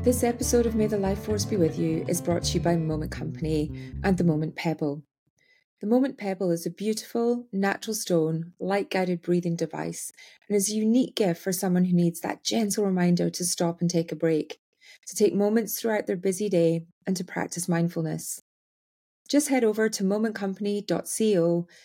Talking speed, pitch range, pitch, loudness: 185 wpm, 165-210 Hz, 180 Hz, -26 LUFS